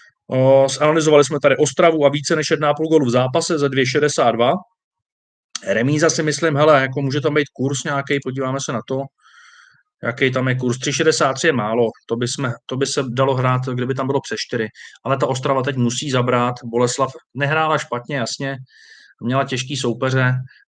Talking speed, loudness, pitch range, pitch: 175 wpm, -18 LUFS, 125-150 Hz, 135 Hz